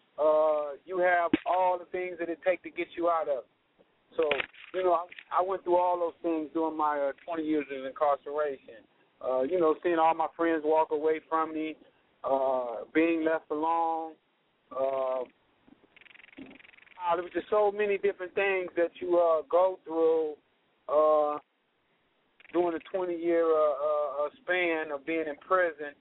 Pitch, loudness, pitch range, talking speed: 165 Hz, -29 LUFS, 155-180 Hz, 165 wpm